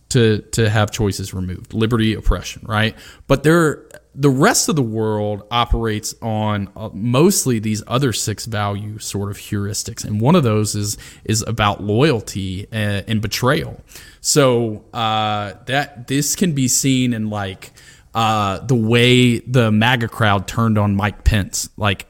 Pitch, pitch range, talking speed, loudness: 110 Hz, 105-125 Hz, 155 wpm, -18 LUFS